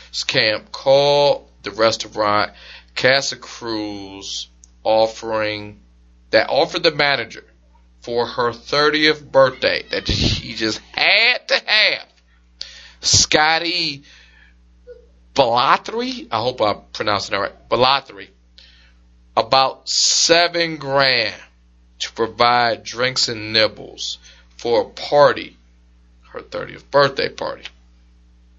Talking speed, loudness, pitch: 95 wpm, -17 LUFS, 105 Hz